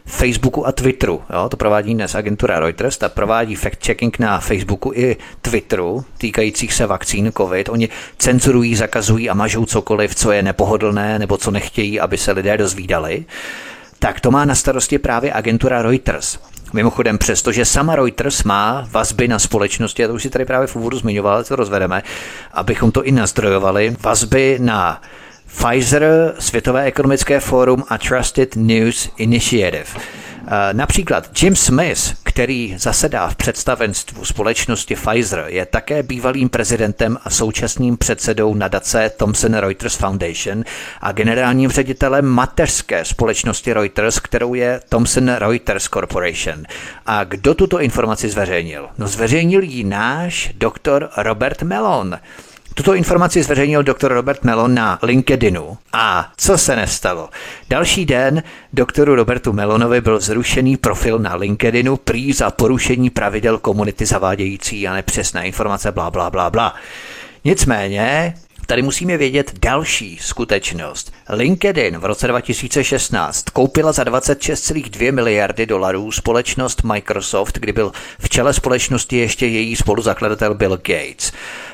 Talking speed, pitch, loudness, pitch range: 135 wpm, 115 Hz, -16 LUFS, 105-130 Hz